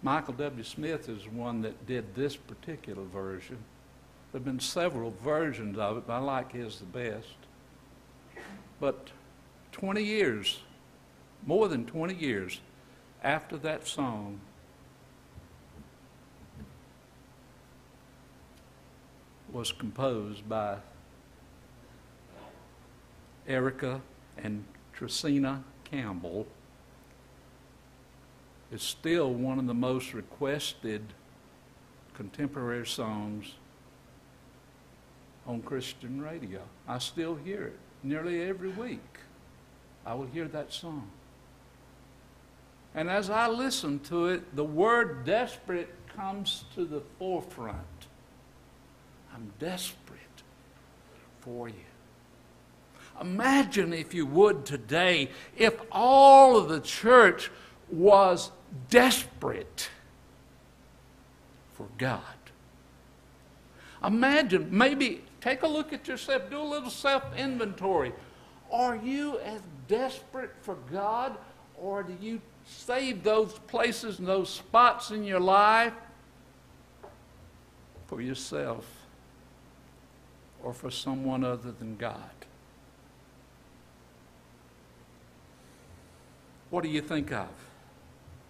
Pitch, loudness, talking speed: 150 Hz, -28 LUFS, 95 wpm